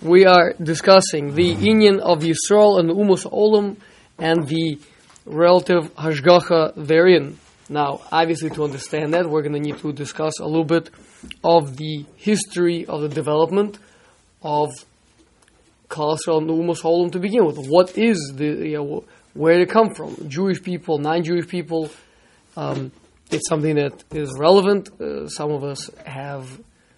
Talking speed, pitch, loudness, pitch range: 150 wpm, 165 Hz, -19 LUFS, 150-180 Hz